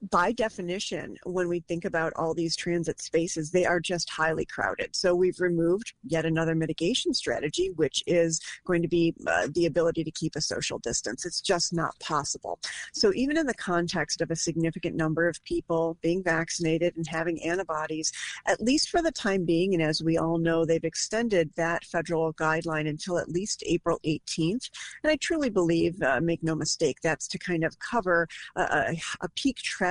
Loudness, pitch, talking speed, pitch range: -28 LUFS, 170 Hz, 185 wpm, 165-180 Hz